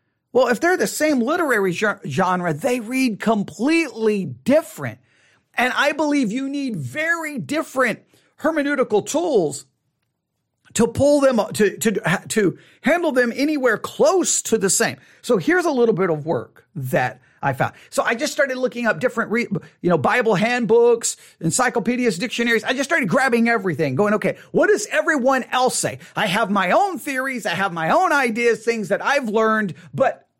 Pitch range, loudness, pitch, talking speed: 210-280 Hz, -20 LUFS, 235 Hz, 165 wpm